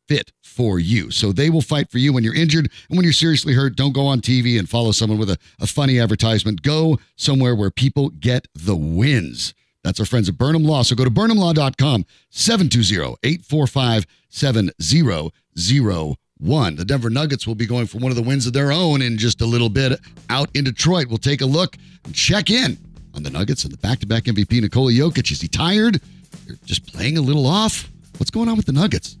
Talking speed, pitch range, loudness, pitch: 215 wpm, 110-145 Hz, -18 LUFS, 130 Hz